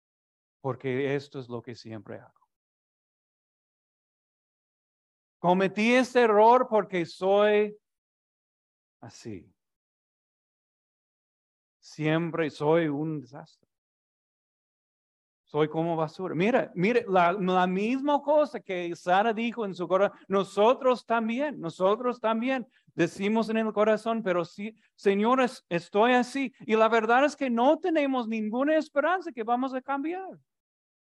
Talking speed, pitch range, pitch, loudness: 110 wpm, 170-245 Hz, 210 Hz, -26 LUFS